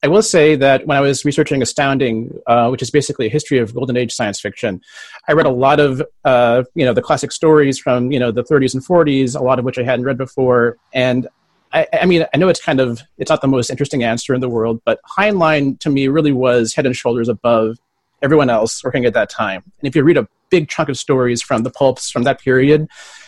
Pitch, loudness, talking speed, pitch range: 130 Hz, -15 LUFS, 245 wpm, 125-145 Hz